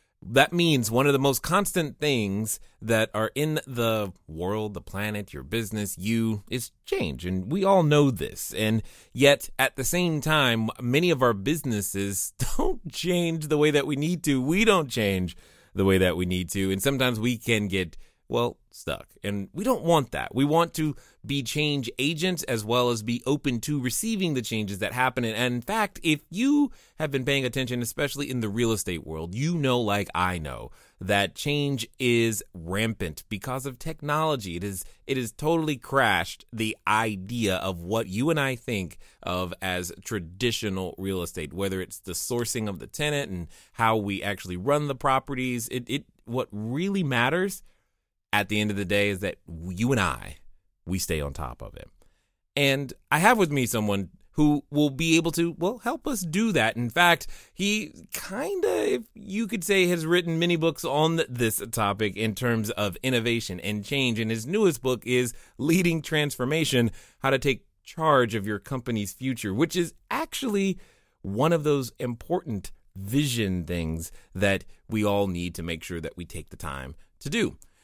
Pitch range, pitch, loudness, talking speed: 100-150 Hz, 120 Hz, -26 LUFS, 185 wpm